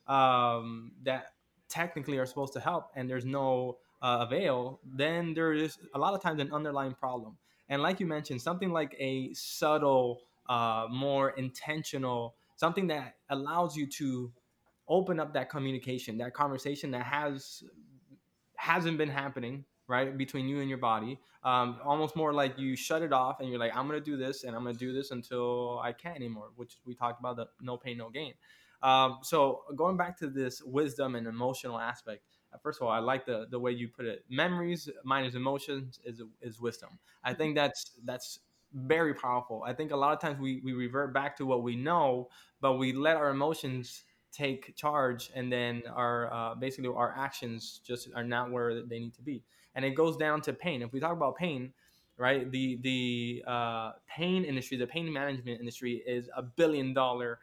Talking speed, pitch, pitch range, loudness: 190 wpm, 130 Hz, 125-145 Hz, -33 LUFS